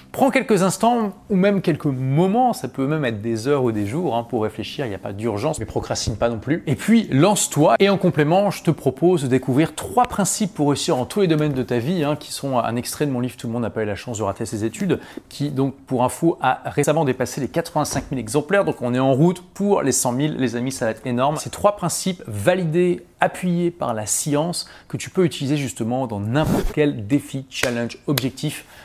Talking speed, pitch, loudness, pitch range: 240 wpm, 145 Hz, -21 LUFS, 125-175 Hz